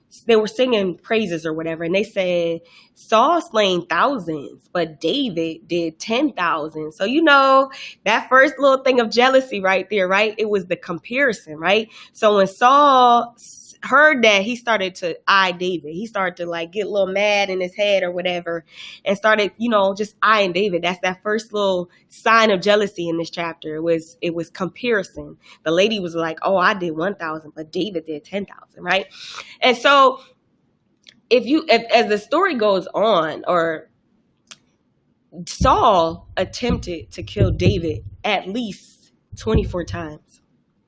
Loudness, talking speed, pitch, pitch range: -18 LUFS, 165 wpm, 195 Hz, 170-230 Hz